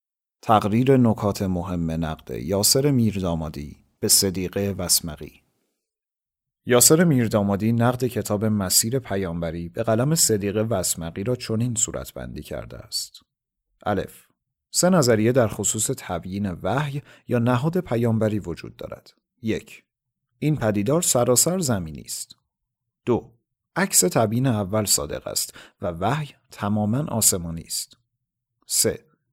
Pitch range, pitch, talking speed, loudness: 95-125 Hz, 110 Hz, 115 wpm, -22 LUFS